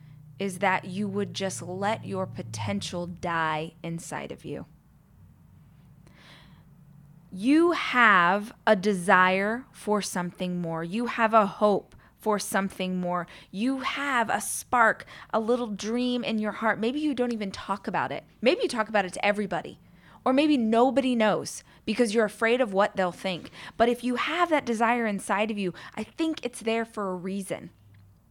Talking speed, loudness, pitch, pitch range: 165 wpm, -26 LUFS, 205 Hz, 180-230 Hz